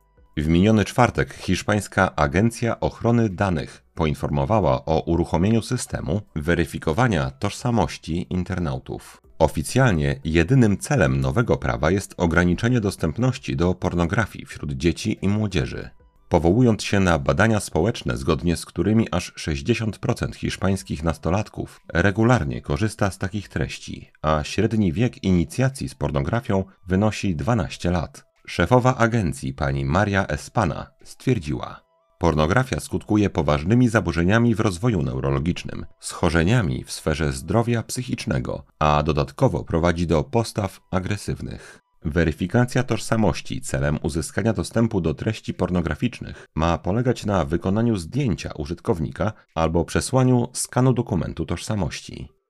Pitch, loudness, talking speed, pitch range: 95 Hz, -22 LUFS, 110 wpm, 80-115 Hz